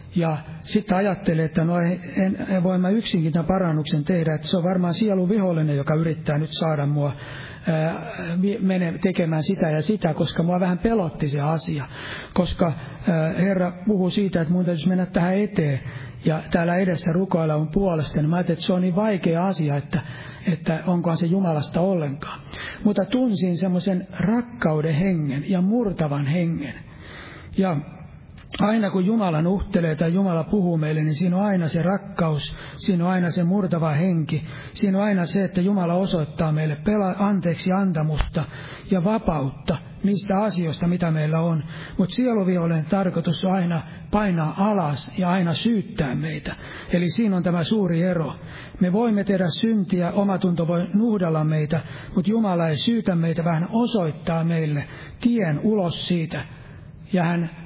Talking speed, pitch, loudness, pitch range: 160 wpm, 175 Hz, -22 LUFS, 155-190 Hz